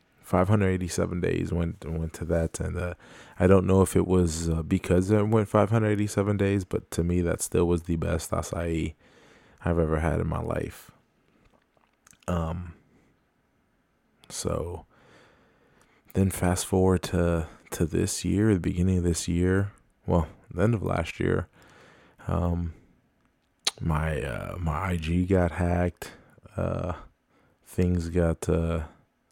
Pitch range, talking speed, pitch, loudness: 85-95 Hz, 135 wpm, 90 Hz, -27 LUFS